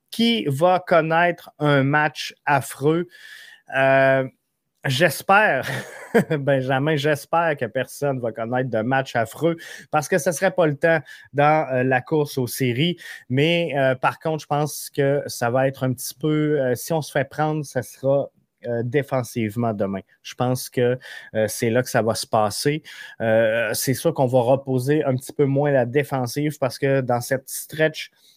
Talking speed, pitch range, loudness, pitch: 175 wpm, 130-155 Hz, -21 LUFS, 140 Hz